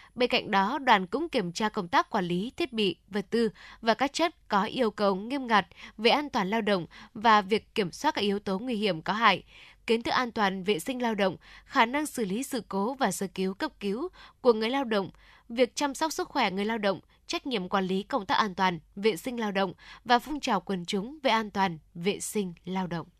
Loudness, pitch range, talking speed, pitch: -28 LUFS, 195-255 Hz, 245 wpm, 220 Hz